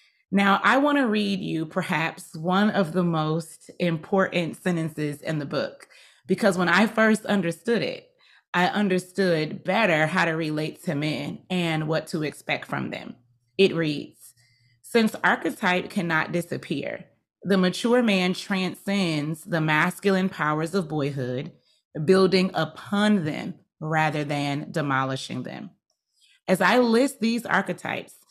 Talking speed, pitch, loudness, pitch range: 135 wpm, 180 Hz, -24 LUFS, 155-200 Hz